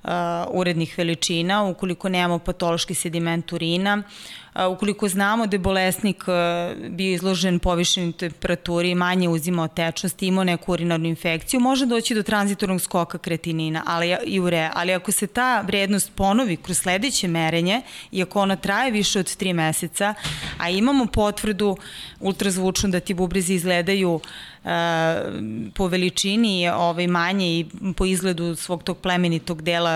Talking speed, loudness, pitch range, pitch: 140 wpm, -22 LUFS, 170-200 Hz, 180 Hz